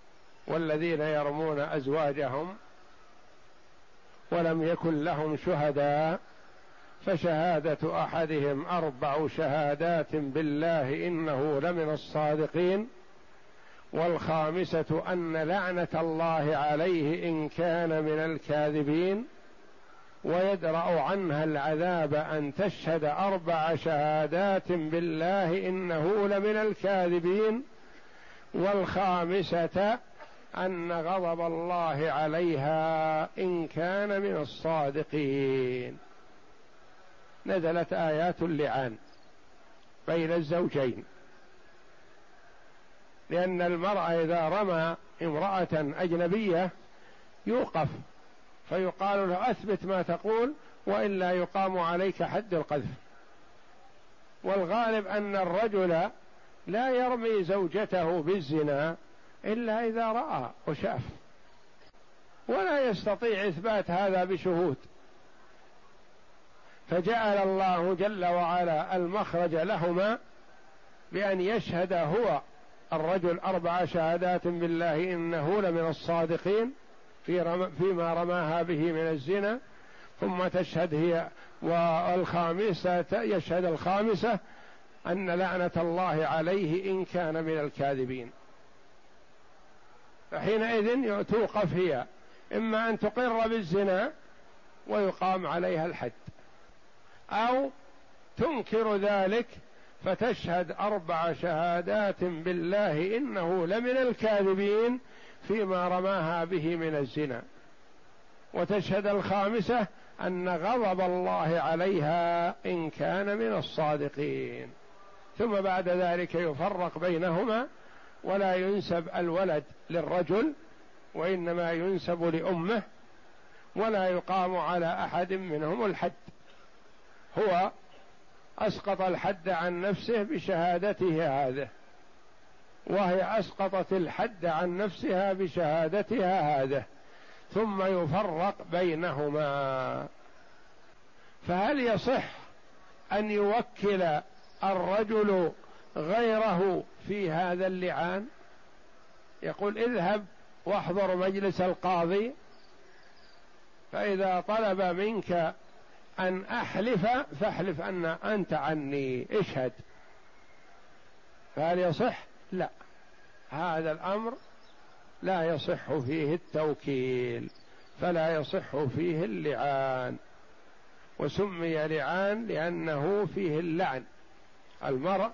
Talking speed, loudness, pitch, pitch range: 80 wpm, -30 LUFS, 175 Hz, 160-195 Hz